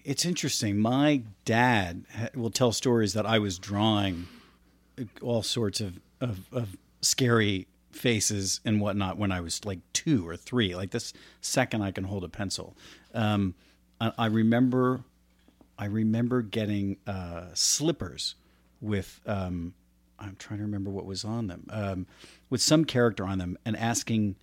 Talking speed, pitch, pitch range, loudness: 150 wpm, 105 Hz, 95-115 Hz, -28 LUFS